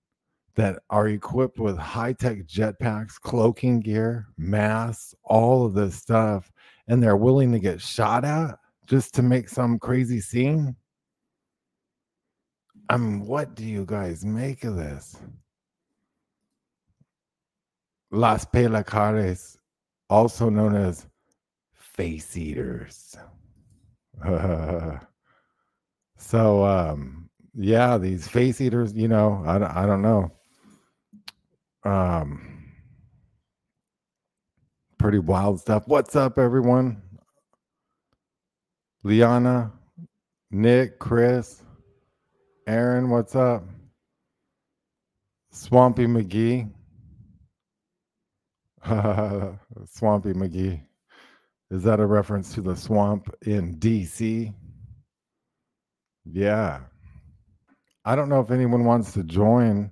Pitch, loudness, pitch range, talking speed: 110 Hz, -23 LUFS, 95-120 Hz, 90 wpm